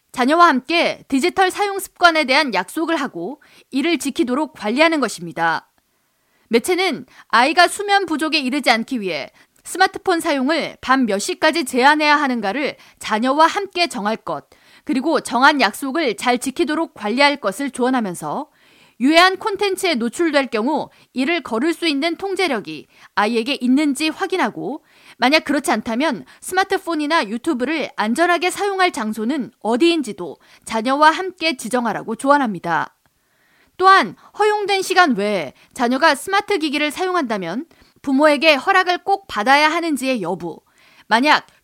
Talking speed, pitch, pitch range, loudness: 325 characters per minute, 300 Hz, 245-345 Hz, -18 LUFS